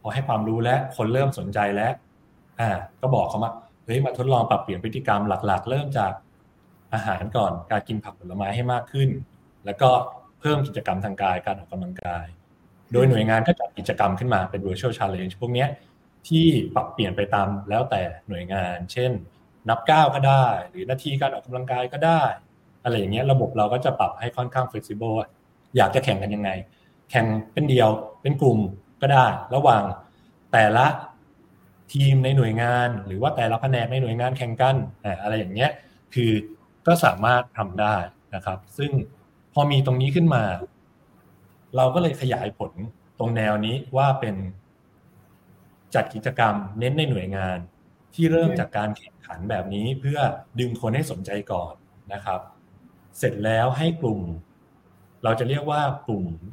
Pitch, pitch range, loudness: 115 Hz, 100-130 Hz, -23 LUFS